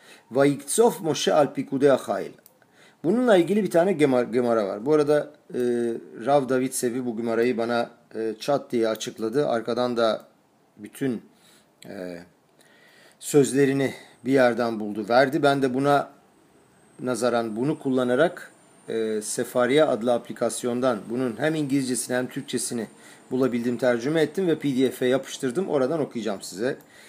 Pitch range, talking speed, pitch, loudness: 120-140 Hz, 125 wpm, 125 Hz, -24 LUFS